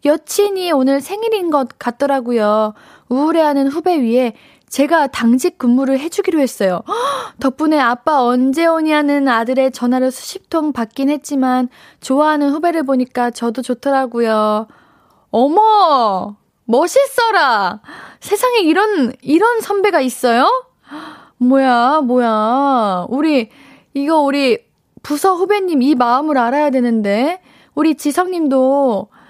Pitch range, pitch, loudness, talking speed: 250-325 Hz, 280 Hz, -15 LUFS, 260 characters per minute